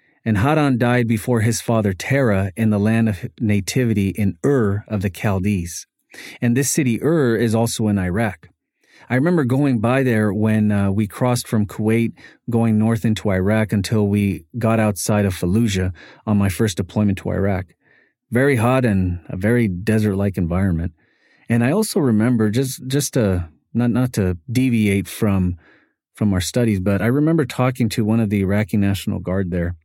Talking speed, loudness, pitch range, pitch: 175 wpm, -19 LUFS, 100-120 Hz, 110 Hz